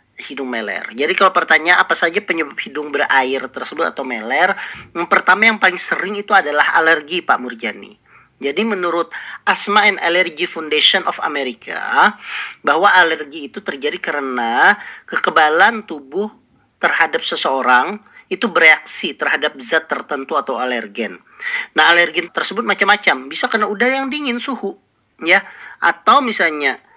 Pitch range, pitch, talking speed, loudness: 165-215 Hz, 190 Hz, 135 wpm, -15 LUFS